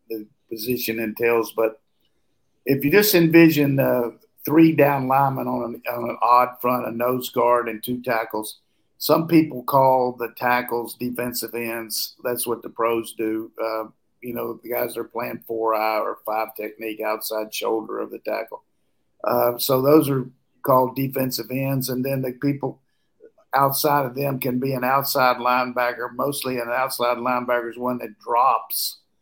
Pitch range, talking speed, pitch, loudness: 115-135 Hz, 165 wpm, 125 Hz, -22 LUFS